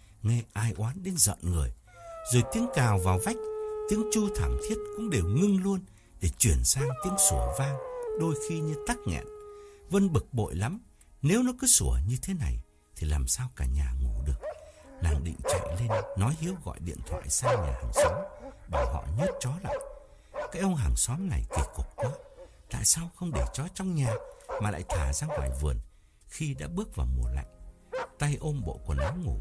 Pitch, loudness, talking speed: 120 Hz, -28 LUFS, 200 wpm